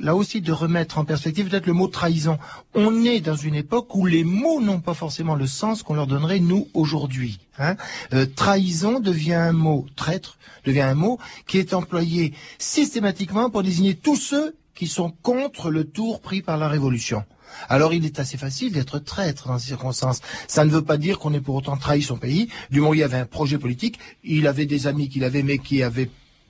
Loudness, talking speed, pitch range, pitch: -22 LUFS, 215 wpm, 140-190 Hz, 160 Hz